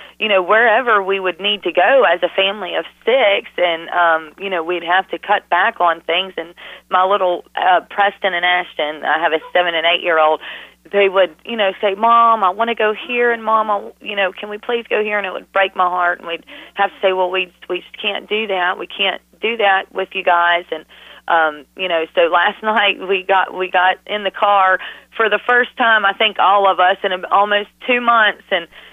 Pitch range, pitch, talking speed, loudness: 180-205 Hz, 190 Hz, 230 wpm, -16 LUFS